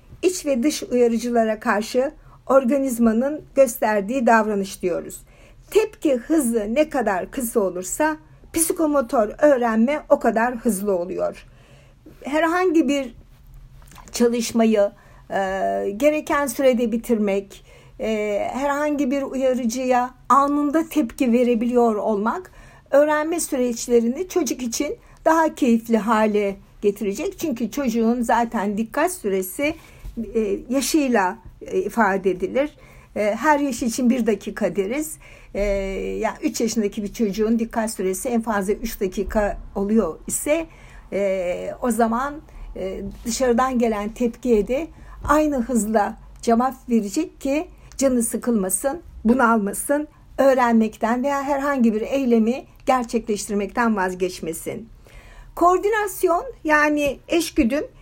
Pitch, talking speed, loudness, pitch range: 240 Hz, 100 wpm, -21 LUFS, 215-285 Hz